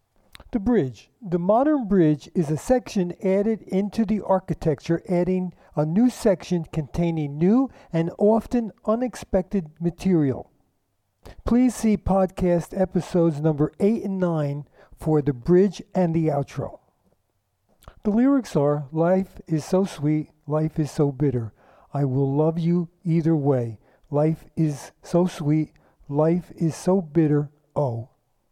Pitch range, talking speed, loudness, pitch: 145-190 Hz, 130 wpm, -23 LUFS, 165 Hz